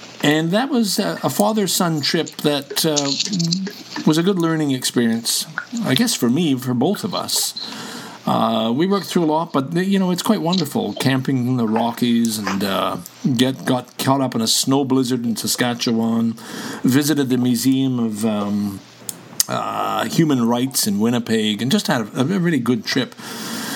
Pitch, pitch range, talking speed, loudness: 135 Hz, 120-175 Hz, 170 wpm, -19 LUFS